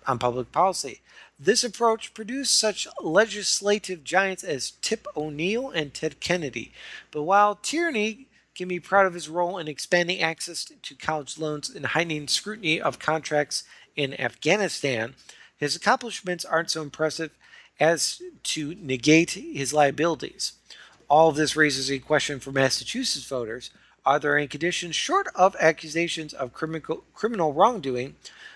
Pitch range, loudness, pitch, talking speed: 145-195 Hz, -25 LUFS, 160 Hz, 135 wpm